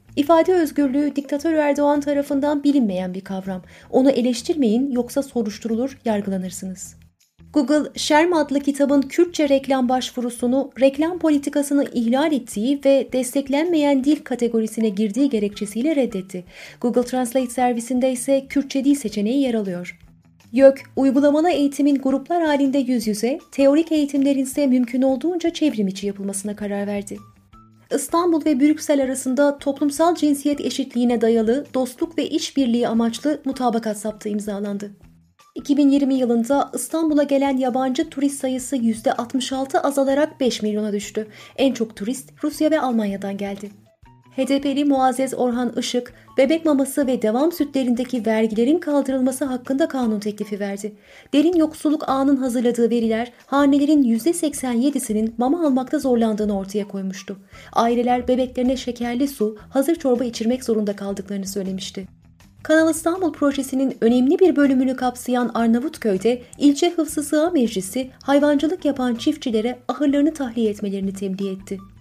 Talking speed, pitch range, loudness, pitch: 125 wpm, 225-285 Hz, -20 LUFS, 260 Hz